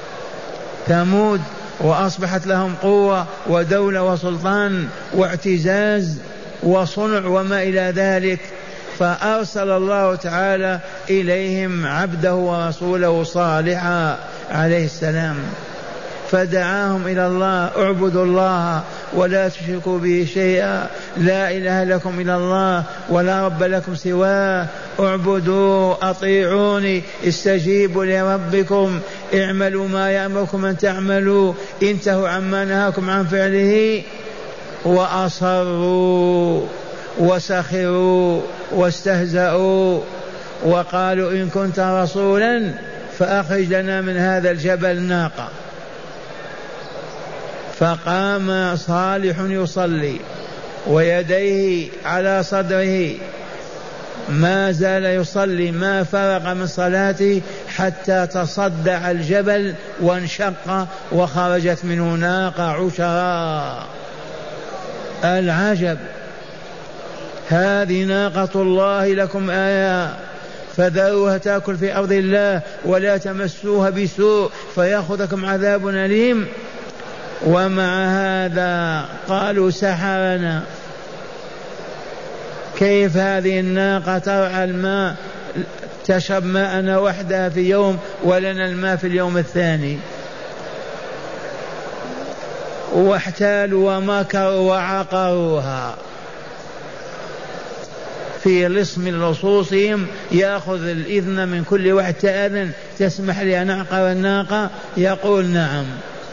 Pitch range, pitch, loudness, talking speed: 180-195 Hz, 190 Hz, -18 LUFS, 80 wpm